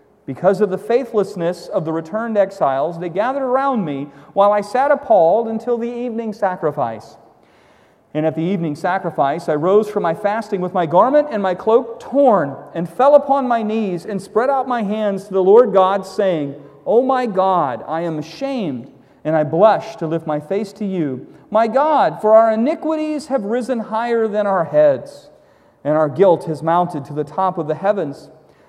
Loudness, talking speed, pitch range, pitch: -17 LUFS, 190 wpm, 165-235 Hz, 200 Hz